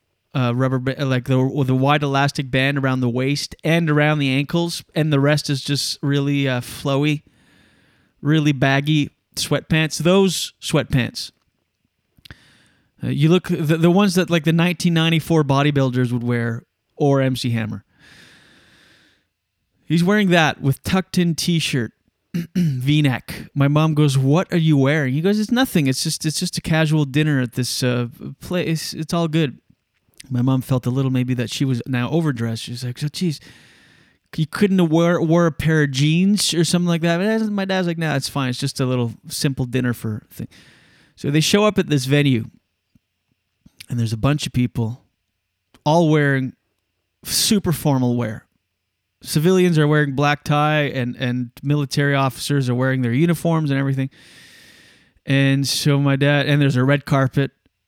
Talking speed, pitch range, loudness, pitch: 165 wpm, 130-160 Hz, -19 LUFS, 140 Hz